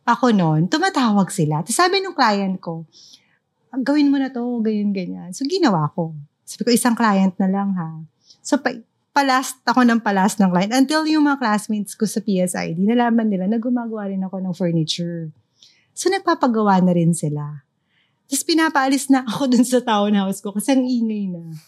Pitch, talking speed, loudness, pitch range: 210 Hz, 175 wpm, -19 LUFS, 175-255 Hz